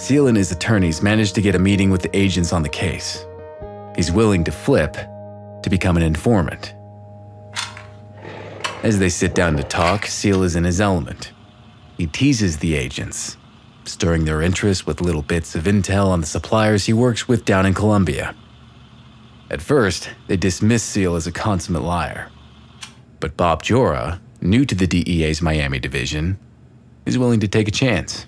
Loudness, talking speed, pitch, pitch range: -19 LUFS, 170 wpm, 100 Hz, 85-105 Hz